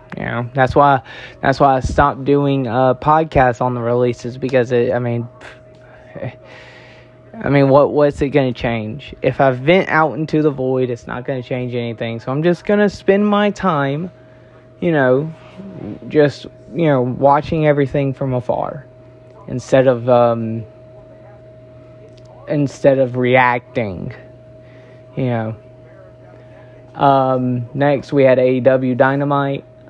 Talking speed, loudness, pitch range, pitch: 140 wpm, -16 LUFS, 125-140 Hz, 130 Hz